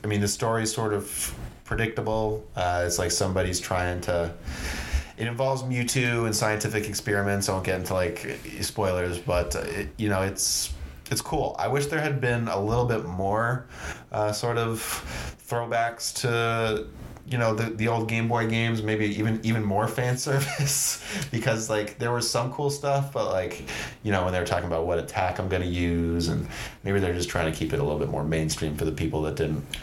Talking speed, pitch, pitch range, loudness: 200 wpm, 105 Hz, 90-115 Hz, -27 LUFS